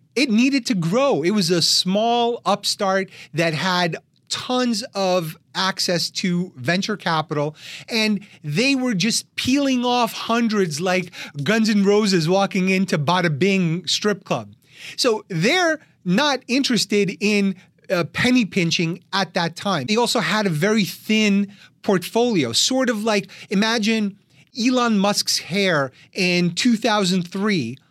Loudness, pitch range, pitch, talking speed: -20 LUFS, 175-225 Hz, 195 Hz, 130 wpm